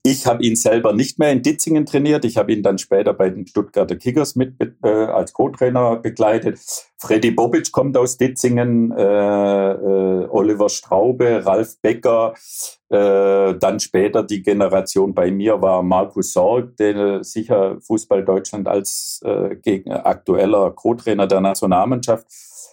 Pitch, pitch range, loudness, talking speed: 110 Hz, 100-125 Hz, -17 LUFS, 145 wpm